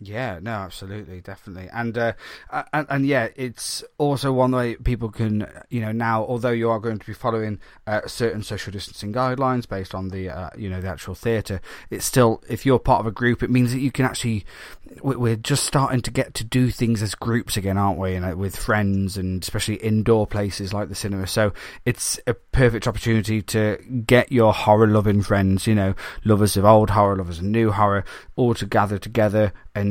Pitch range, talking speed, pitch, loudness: 100-120 Hz, 205 wpm, 110 Hz, -22 LUFS